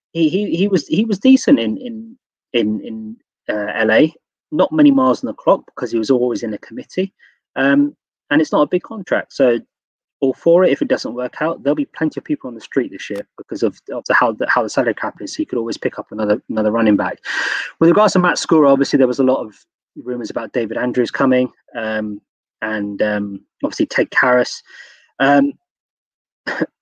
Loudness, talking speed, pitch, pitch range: -17 LUFS, 215 wpm, 140 Hz, 125-195 Hz